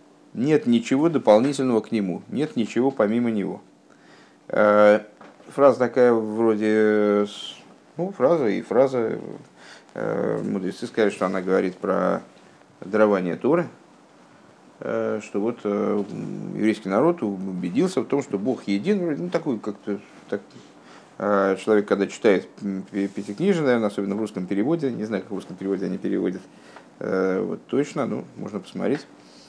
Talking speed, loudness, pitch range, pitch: 120 wpm, -23 LUFS, 100-115 Hz, 105 Hz